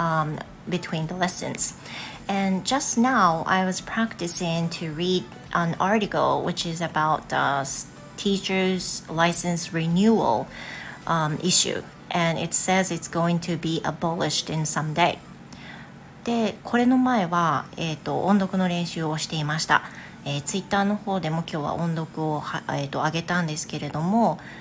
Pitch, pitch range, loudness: 170 Hz, 160-190 Hz, -24 LUFS